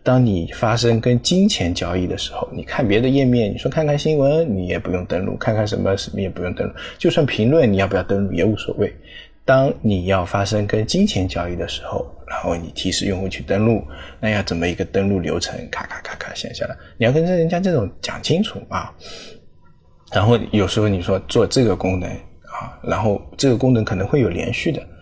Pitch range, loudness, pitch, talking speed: 95-125 Hz, -19 LUFS, 105 Hz, 315 characters per minute